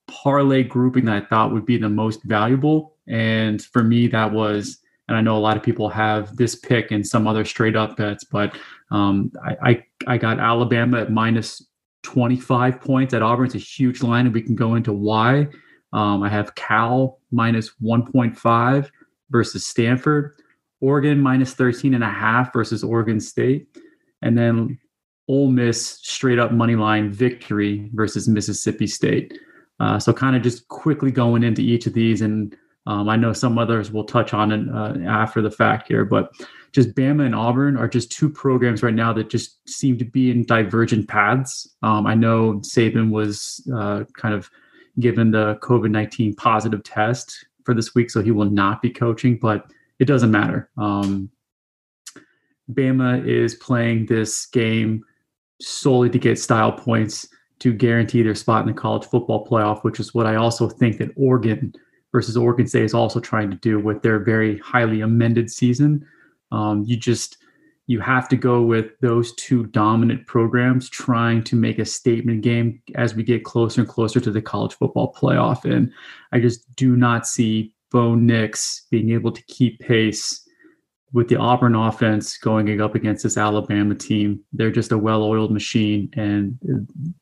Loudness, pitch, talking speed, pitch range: -19 LUFS, 115 Hz, 175 wpm, 110-125 Hz